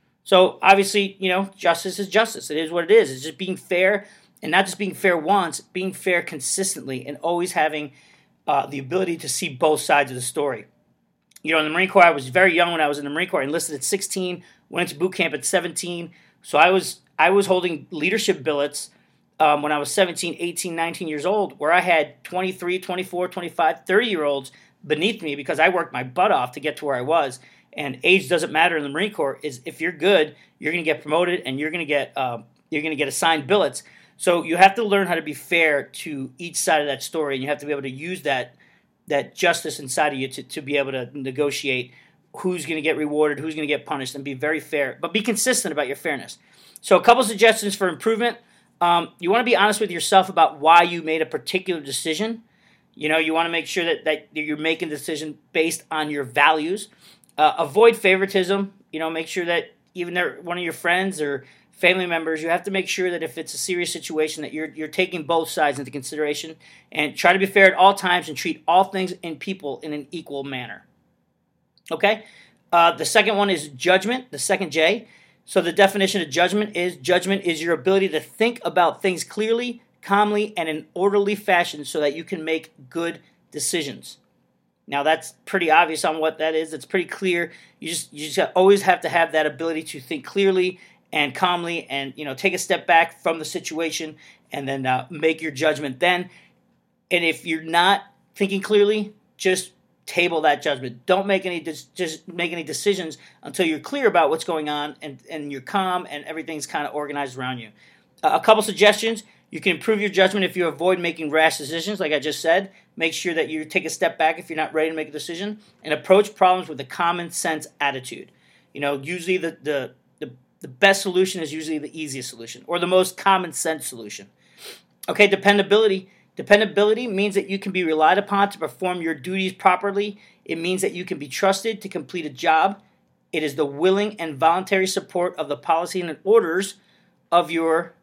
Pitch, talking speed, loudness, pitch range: 170 Hz, 220 wpm, -21 LUFS, 155-190 Hz